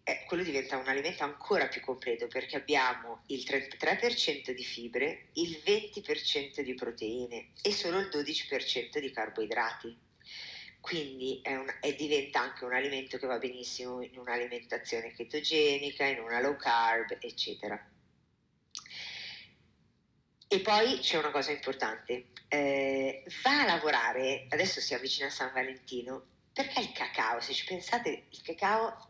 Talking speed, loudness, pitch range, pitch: 135 wpm, -33 LUFS, 130-180 Hz, 140 Hz